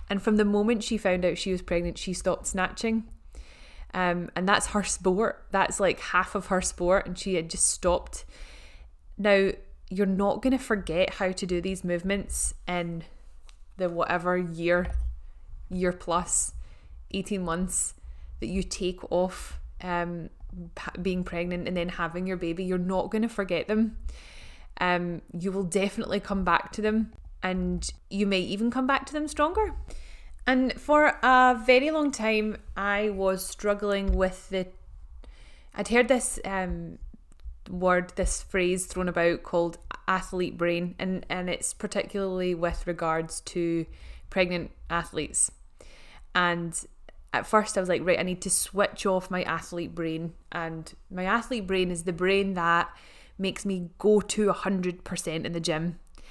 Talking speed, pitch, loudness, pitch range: 160 wpm, 185 Hz, -27 LUFS, 170-200 Hz